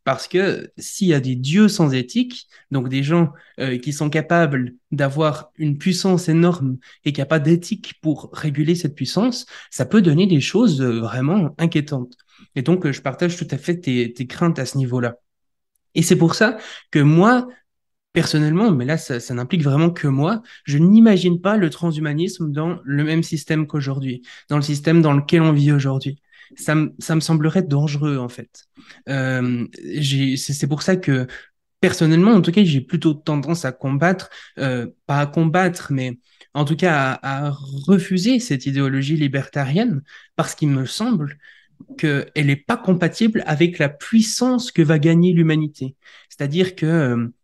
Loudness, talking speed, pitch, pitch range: -19 LUFS, 175 wpm, 155 Hz, 140-175 Hz